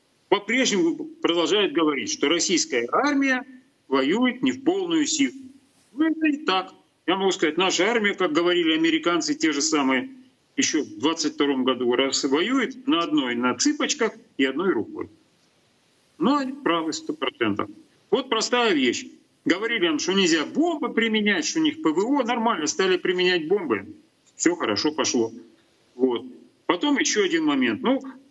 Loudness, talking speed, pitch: -23 LUFS, 145 wpm, 260 Hz